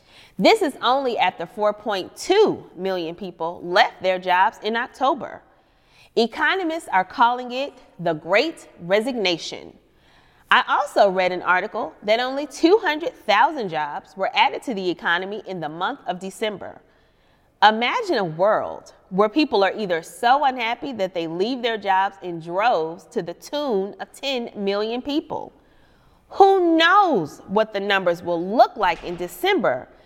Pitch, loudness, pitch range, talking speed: 210 Hz, -21 LUFS, 185-285 Hz, 140 wpm